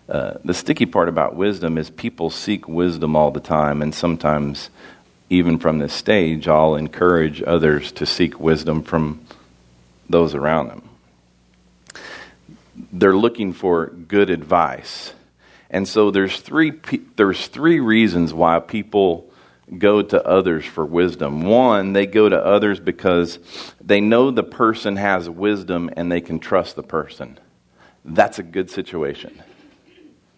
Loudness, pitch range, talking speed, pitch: -18 LUFS, 75-100 Hz, 140 wpm, 85 Hz